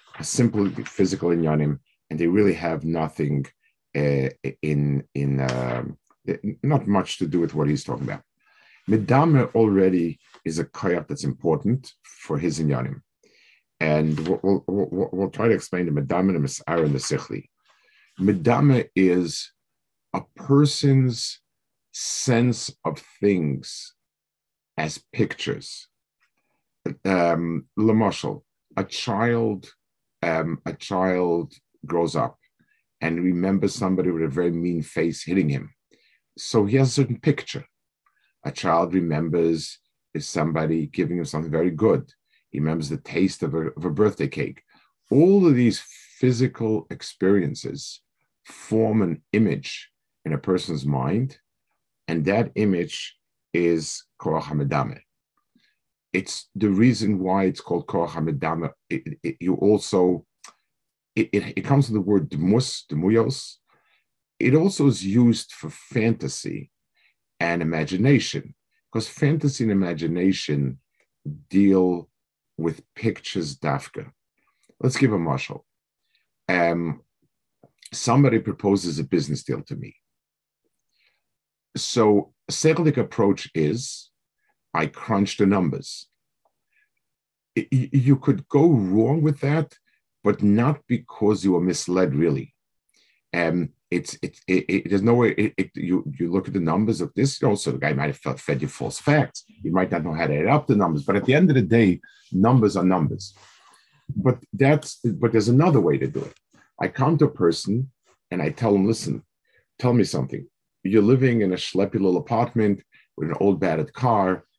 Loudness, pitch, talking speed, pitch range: -23 LUFS, 100 Hz, 140 wpm, 85-120 Hz